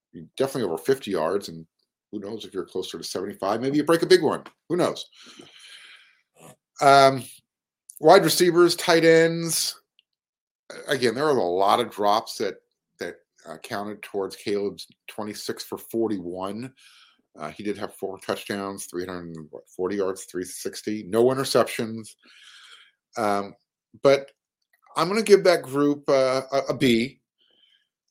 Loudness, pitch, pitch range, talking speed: -23 LUFS, 120 Hz, 100-150 Hz, 135 wpm